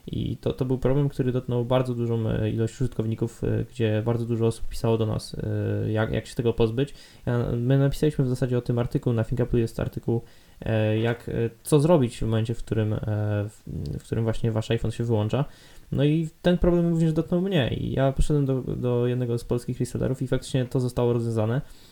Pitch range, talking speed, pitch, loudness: 110-135 Hz, 190 wpm, 120 Hz, -26 LUFS